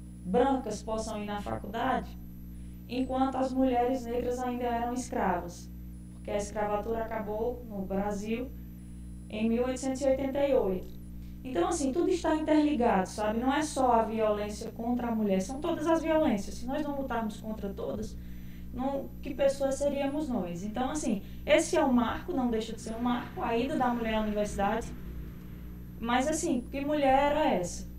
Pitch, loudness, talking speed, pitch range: 230 Hz, -30 LUFS, 160 wpm, 200-270 Hz